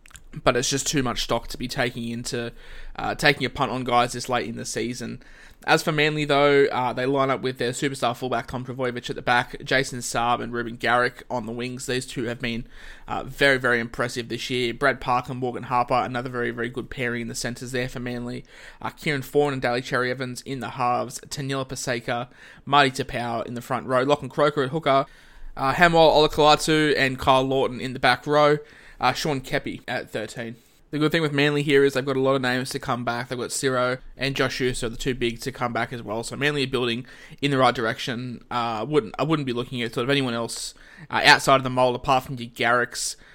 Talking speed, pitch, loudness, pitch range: 230 wpm, 125 Hz, -23 LUFS, 120-140 Hz